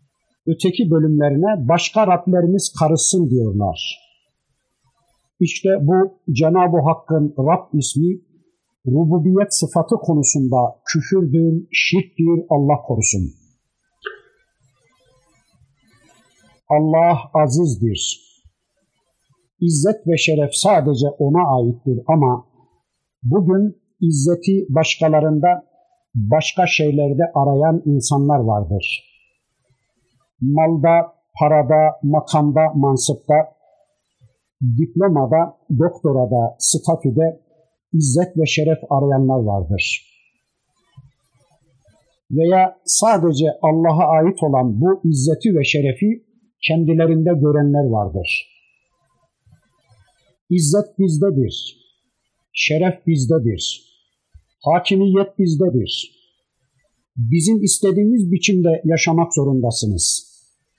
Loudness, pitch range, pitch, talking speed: -17 LUFS, 135-175 Hz, 155 Hz, 70 wpm